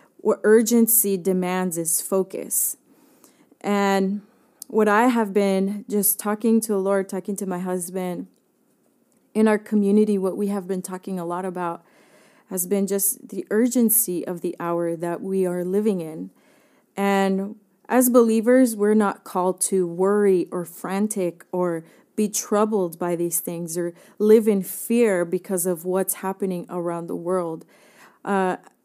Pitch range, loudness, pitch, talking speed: 180-215 Hz, -22 LUFS, 195 Hz, 150 wpm